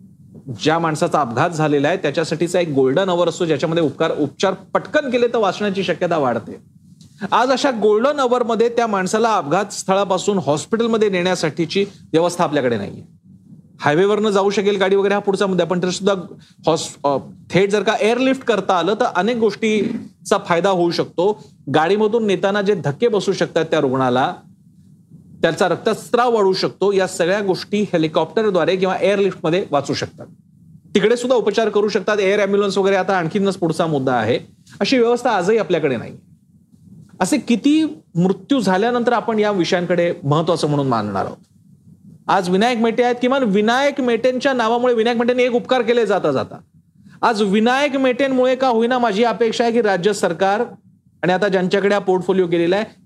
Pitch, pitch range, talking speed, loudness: 195 Hz, 175-230 Hz, 155 wpm, -18 LUFS